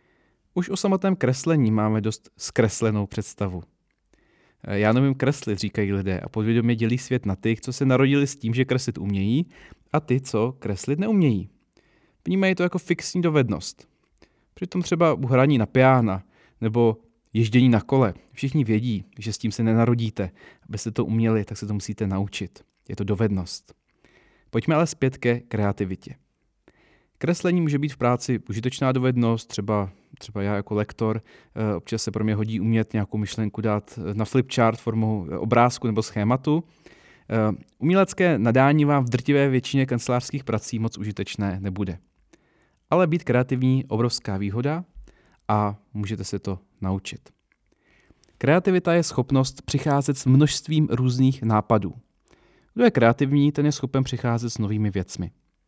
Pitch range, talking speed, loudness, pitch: 105-135 Hz, 150 wpm, -23 LUFS, 115 Hz